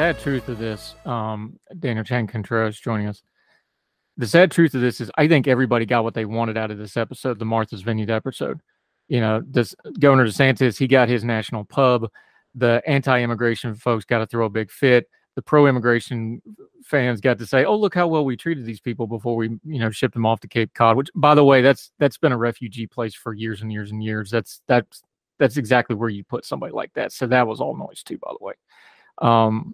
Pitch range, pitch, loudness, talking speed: 110-135 Hz, 120 Hz, -20 LUFS, 220 wpm